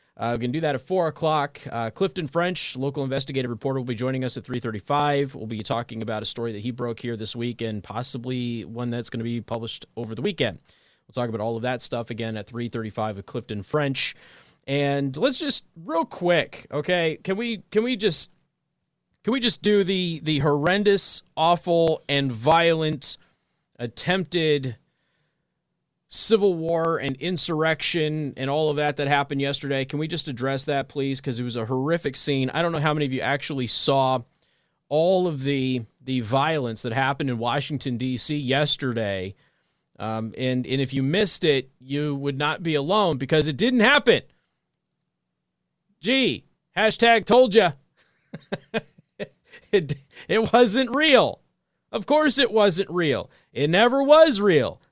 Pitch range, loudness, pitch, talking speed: 125-170 Hz, -23 LUFS, 140 Hz, 170 wpm